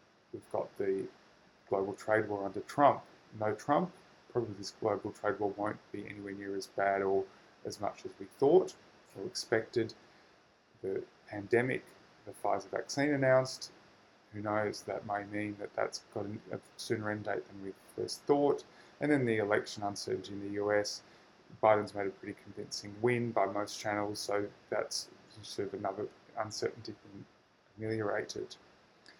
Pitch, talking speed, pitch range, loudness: 105 Hz, 155 wpm, 100-130 Hz, -35 LUFS